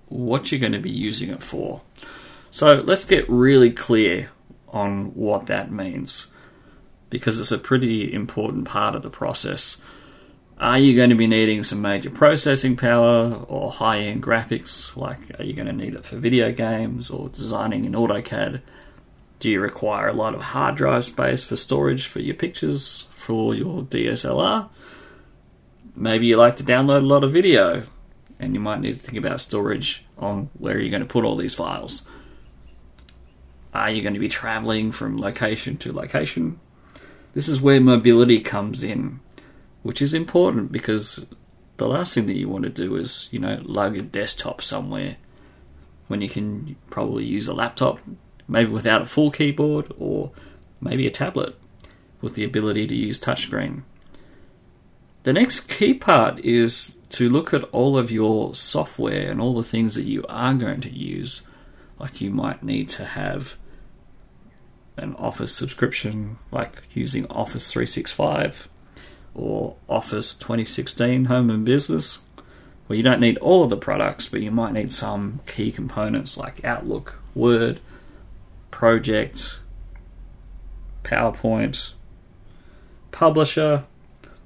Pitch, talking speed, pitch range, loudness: 115 Hz, 155 wpm, 105-130 Hz, -21 LUFS